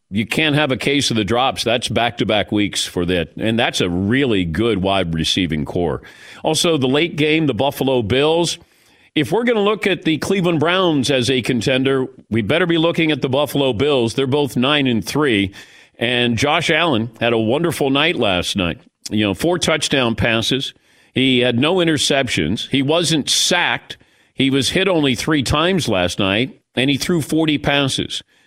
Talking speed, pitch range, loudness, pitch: 190 wpm, 115-155 Hz, -17 LUFS, 135 Hz